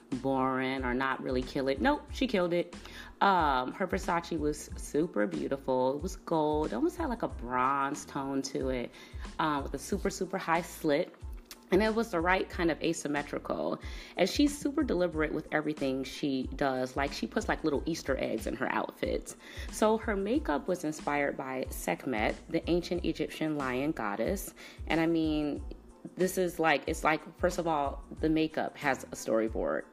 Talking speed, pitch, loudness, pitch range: 180 wpm, 155 Hz, -32 LUFS, 135-180 Hz